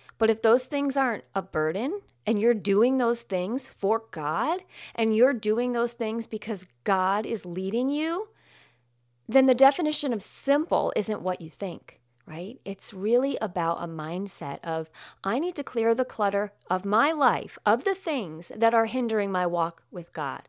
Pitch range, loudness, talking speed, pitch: 185-250 Hz, -26 LUFS, 175 wpm, 220 Hz